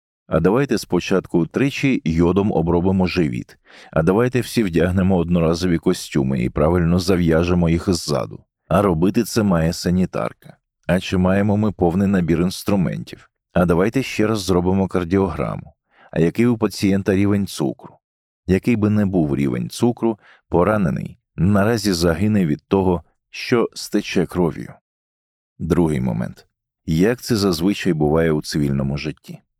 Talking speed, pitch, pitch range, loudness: 130 wpm, 95 Hz, 85-100 Hz, -19 LUFS